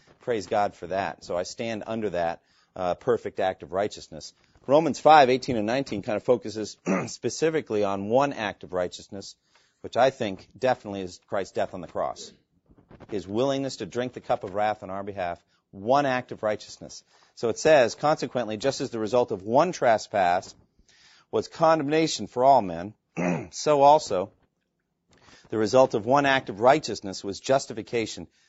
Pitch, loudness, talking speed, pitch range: 110 Hz, -25 LUFS, 170 wpm, 100-135 Hz